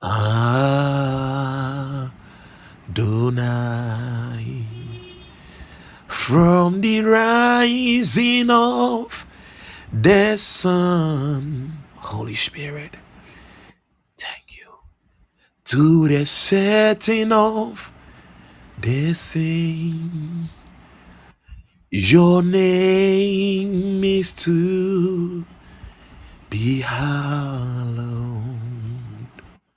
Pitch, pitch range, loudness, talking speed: 145 Hz, 120-185 Hz, -18 LUFS, 50 wpm